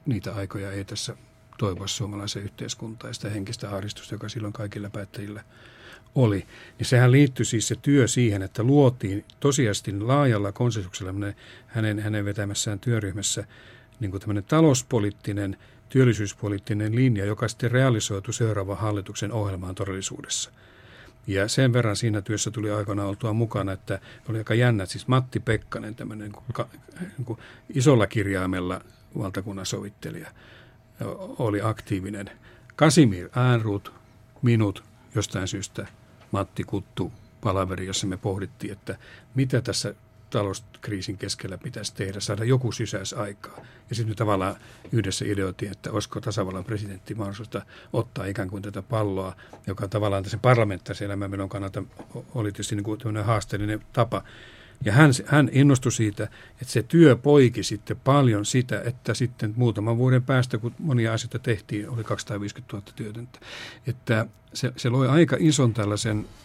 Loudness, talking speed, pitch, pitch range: -25 LUFS, 140 wpm, 110 Hz, 100-120 Hz